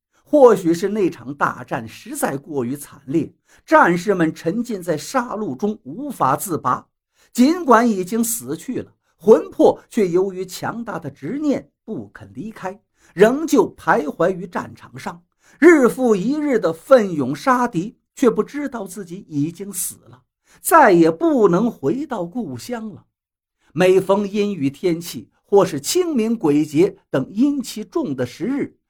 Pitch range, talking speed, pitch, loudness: 180-255 Hz, 210 characters per minute, 210 Hz, -18 LUFS